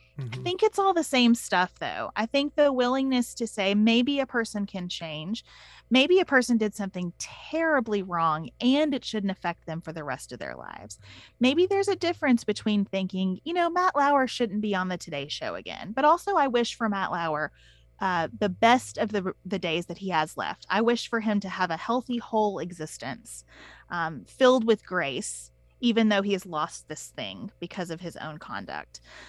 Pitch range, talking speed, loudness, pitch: 170-255 Hz, 200 wpm, -26 LUFS, 210 Hz